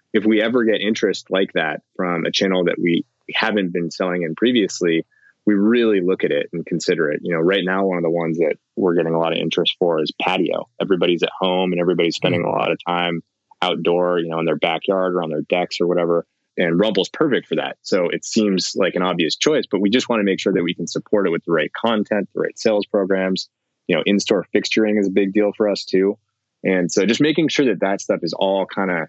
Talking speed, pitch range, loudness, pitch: 250 wpm, 85-105 Hz, -19 LUFS, 95 Hz